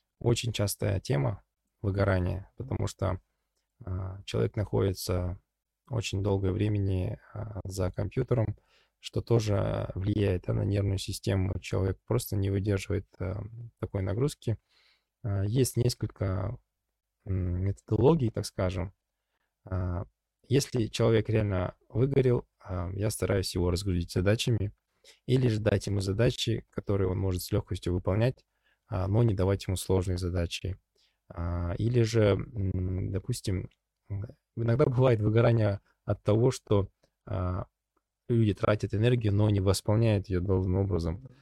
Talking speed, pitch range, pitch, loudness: 105 wpm, 95-115 Hz, 100 Hz, -30 LUFS